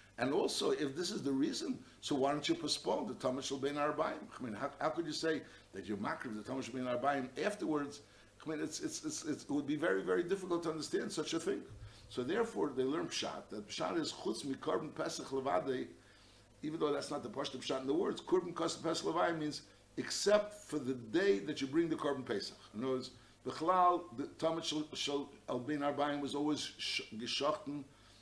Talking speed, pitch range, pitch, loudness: 205 wpm, 130-175 Hz, 150 Hz, -38 LUFS